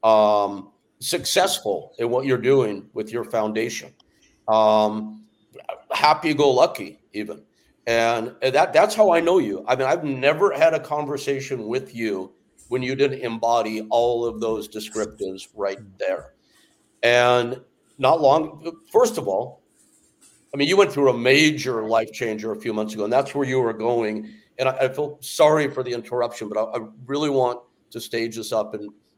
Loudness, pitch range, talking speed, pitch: -21 LUFS, 110-140 Hz, 165 wpm, 120 Hz